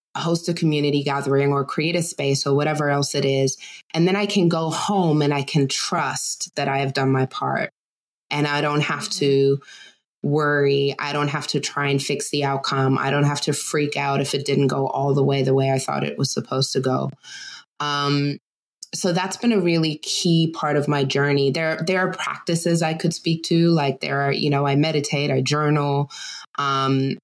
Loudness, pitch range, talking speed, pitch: -21 LUFS, 140-160 Hz, 210 wpm, 145 Hz